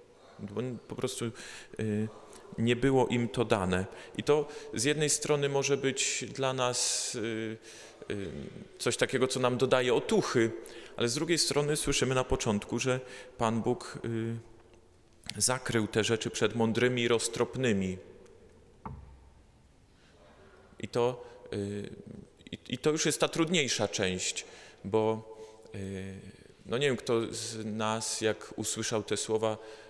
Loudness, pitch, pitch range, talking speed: -31 LUFS, 115 Hz, 110-130 Hz, 130 wpm